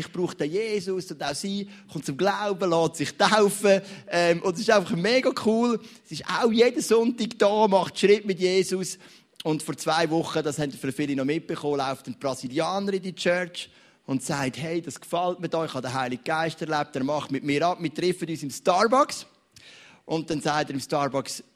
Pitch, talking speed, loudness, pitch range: 170 Hz, 210 wpm, -25 LUFS, 150-195 Hz